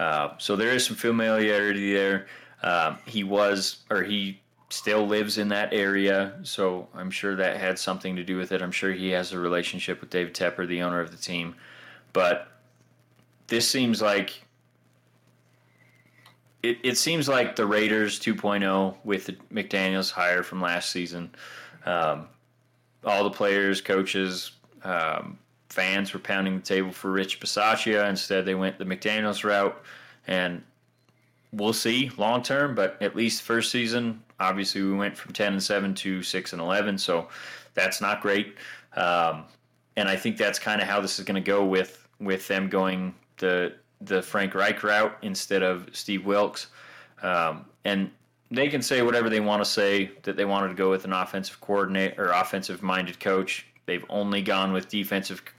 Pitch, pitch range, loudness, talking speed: 100 Hz, 95-105 Hz, -26 LUFS, 170 wpm